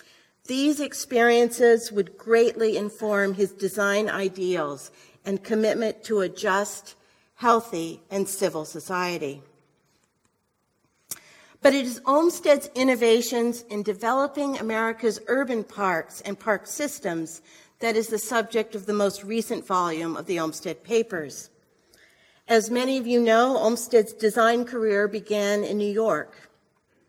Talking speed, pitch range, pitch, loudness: 120 wpm, 195-235 Hz, 215 Hz, -24 LUFS